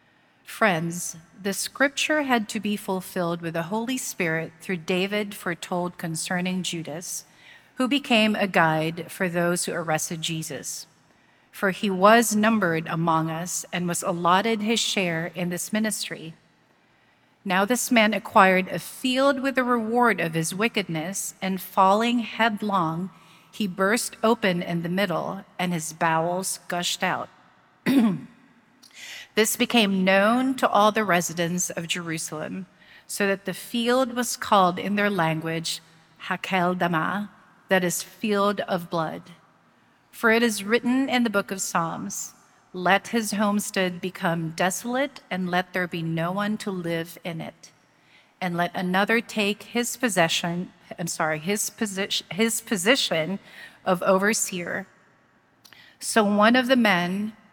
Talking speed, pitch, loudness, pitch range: 140 wpm, 190 Hz, -24 LUFS, 175-220 Hz